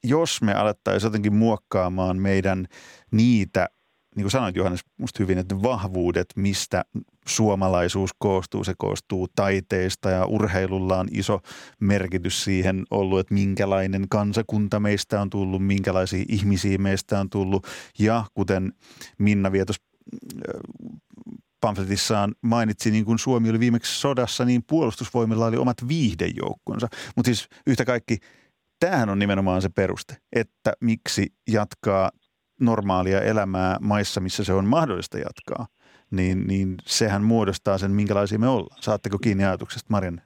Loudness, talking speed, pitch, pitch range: -24 LUFS, 135 wpm, 100 Hz, 95-115 Hz